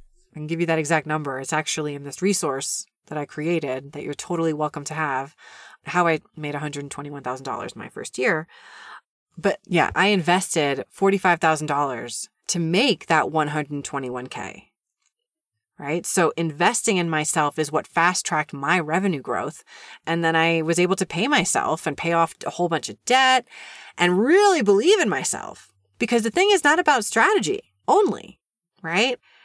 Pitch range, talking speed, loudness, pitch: 150-195 Hz, 180 wpm, -22 LUFS, 165 Hz